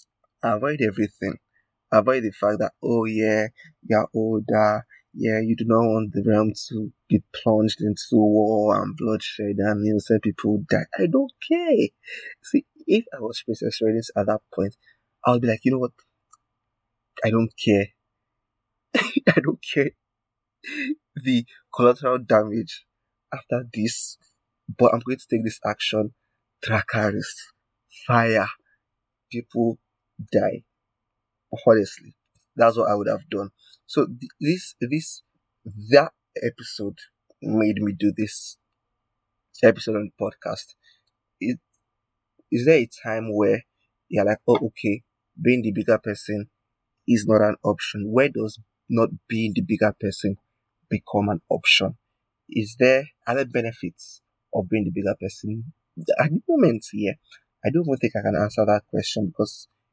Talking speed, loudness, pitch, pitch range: 145 wpm, -23 LUFS, 110 Hz, 105-120 Hz